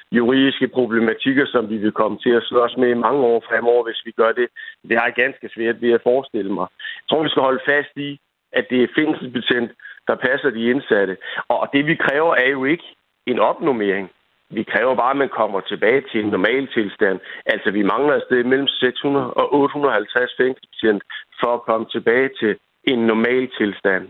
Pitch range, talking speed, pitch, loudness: 115-135 Hz, 195 wpm, 125 Hz, -19 LUFS